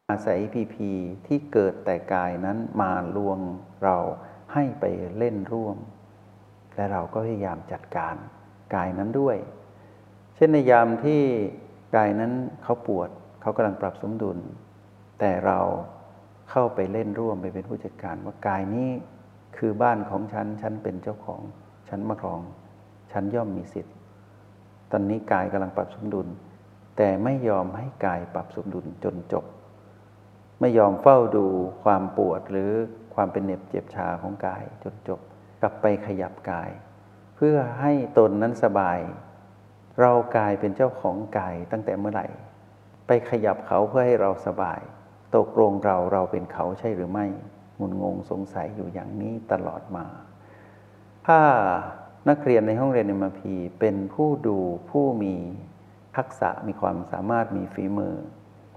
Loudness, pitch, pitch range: -25 LUFS, 100 Hz, 95-110 Hz